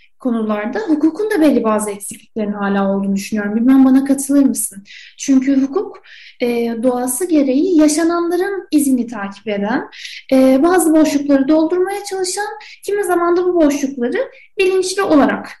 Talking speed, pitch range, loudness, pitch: 130 wpm, 235-365 Hz, -15 LUFS, 285 Hz